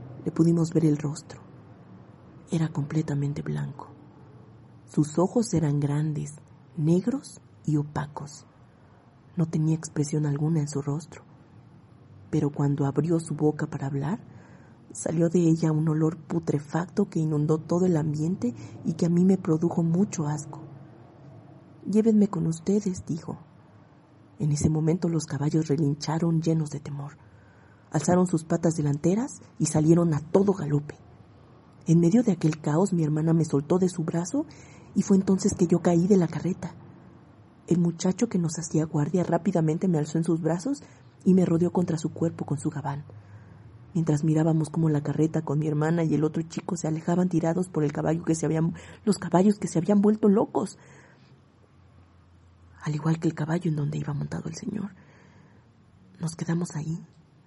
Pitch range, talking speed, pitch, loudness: 145-170 Hz, 160 wpm, 155 Hz, -26 LUFS